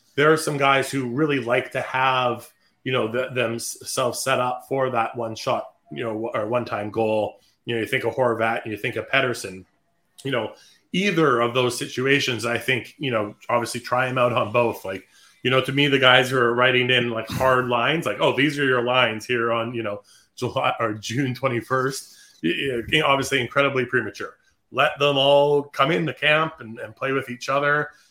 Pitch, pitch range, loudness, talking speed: 125 Hz, 120-135 Hz, -22 LUFS, 210 wpm